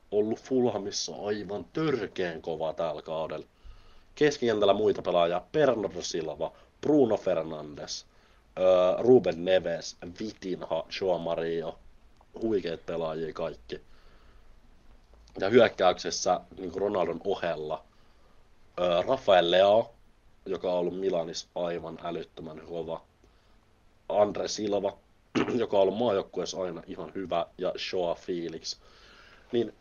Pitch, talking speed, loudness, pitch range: 95 Hz, 100 wpm, -29 LUFS, 85-105 Hz